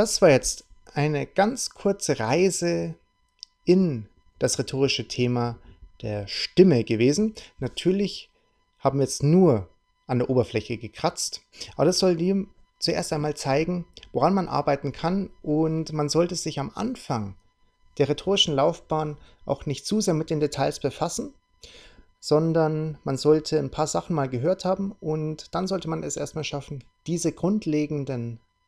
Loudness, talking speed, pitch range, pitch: -25 LUFS, 145 wpm, 135-175 Hz, 150 Hz